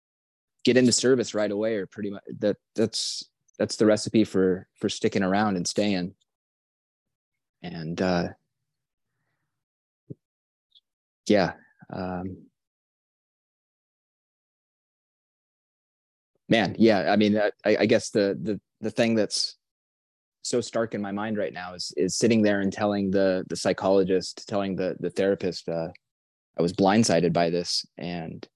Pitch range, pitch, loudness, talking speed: 90-110 Hz, 100 Hz, -25 LUFS, 130 wpm